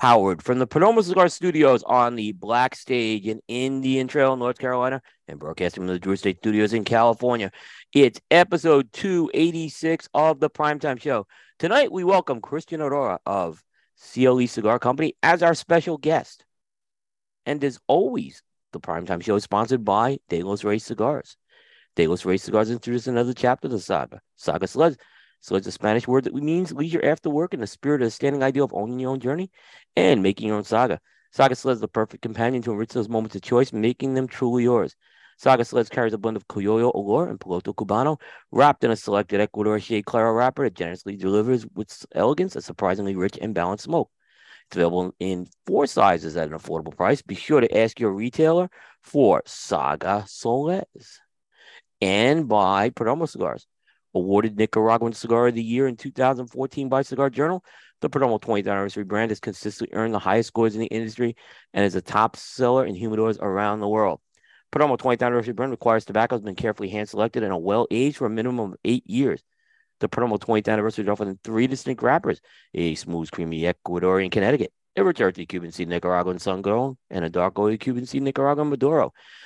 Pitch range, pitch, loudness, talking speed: 105-135 Hz, 115 Hz, -23 LUFS, 185 wpm